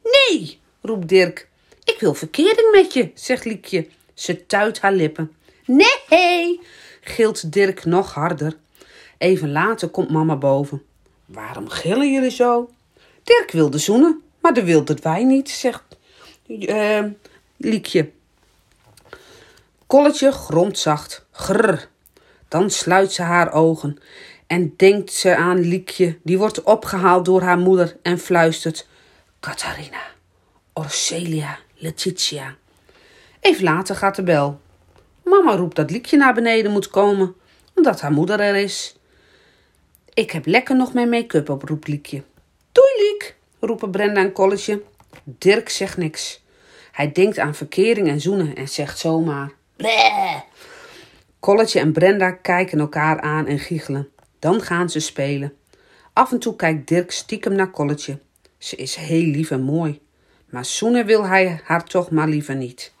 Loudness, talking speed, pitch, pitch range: -18 LUFS, 140 wpm, 185 Hz, 160-230 Hz